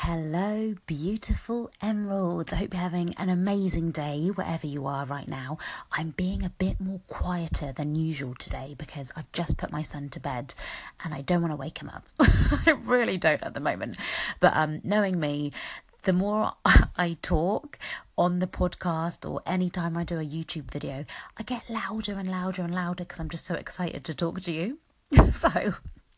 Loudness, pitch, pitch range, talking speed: -28 LUFS, 175 Hz, 155-190 Hz, 190 wpm